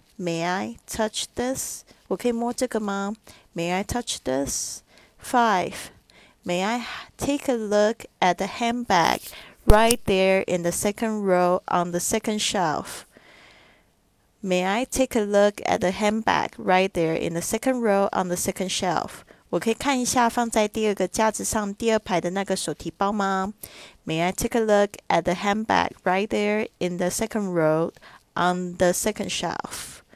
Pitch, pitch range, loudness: 195 Hz, 180-220 Hz, -24 LUFS